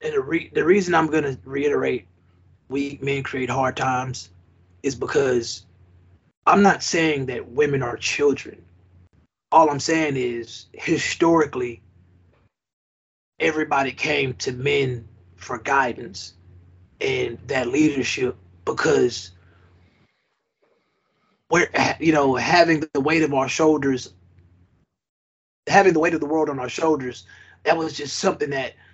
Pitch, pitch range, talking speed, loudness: 130 Hz, 90-150 Hz, 125 wpm, -21 LUFS